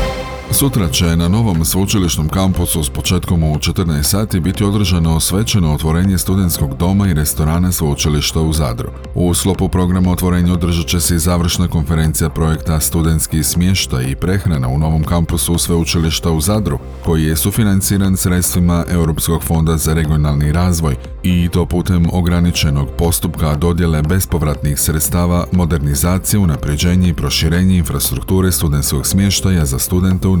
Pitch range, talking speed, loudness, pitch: 80-90 Hz, 140 wpm, -14 LUFS, 85 Hz